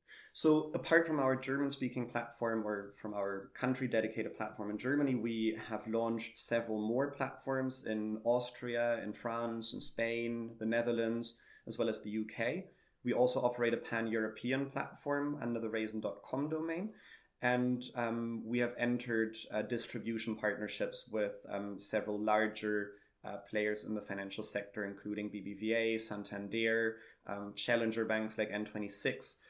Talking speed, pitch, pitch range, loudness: 140 wpm, 115 Hz, 105-120 Hz, -37 LUFS